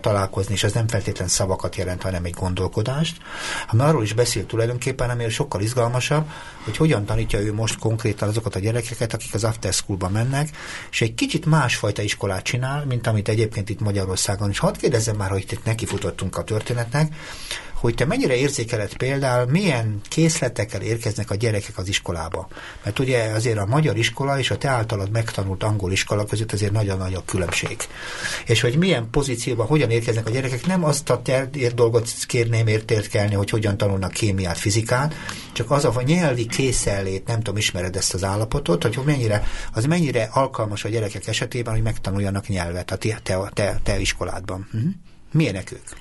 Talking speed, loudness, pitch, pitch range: 175 wpm, -22 LUFS, 115 Hz, 100-125 Hz